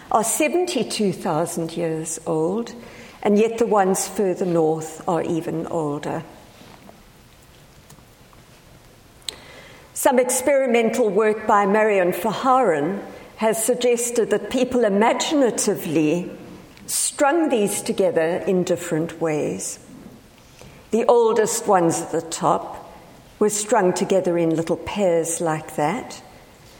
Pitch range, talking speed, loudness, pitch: 165-230 Hz, 100 wpm, -21 LUFS, 195 Hz